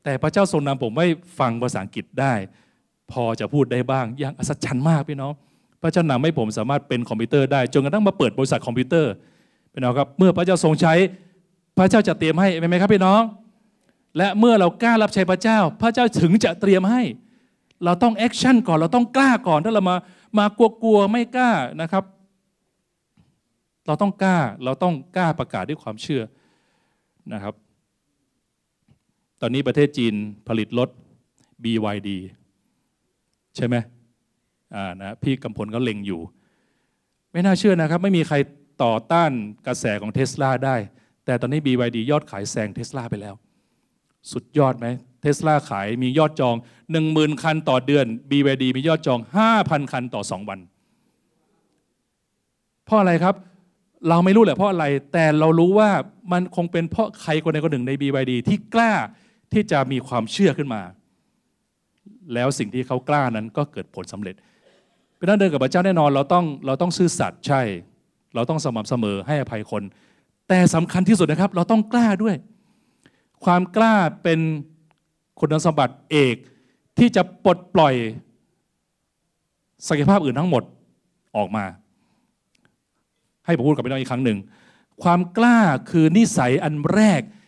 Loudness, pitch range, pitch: -20 LUFS, 125-190 Hz, 155 Hz